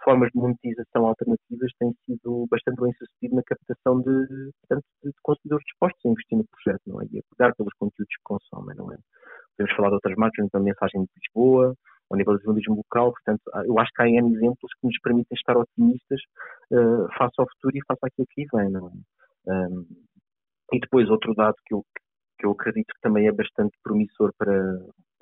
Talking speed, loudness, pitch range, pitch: 200 wpm, -24 LUFS, 105-130 Hz, 120 Hz